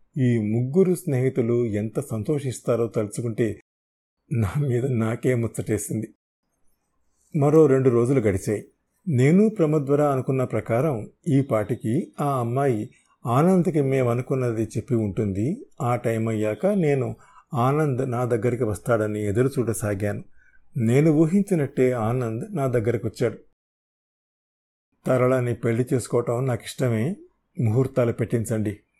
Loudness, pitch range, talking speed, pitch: -23 LUFS, 115-140 Hz, 100 wpm, 125 Hz